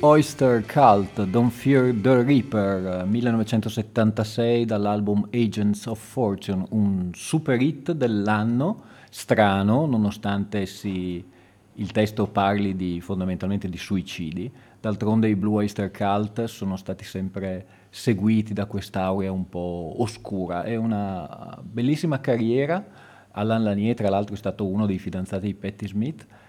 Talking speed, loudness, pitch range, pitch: 125 wpm, -24 LUFS, 95-115 Hz, 105 Hz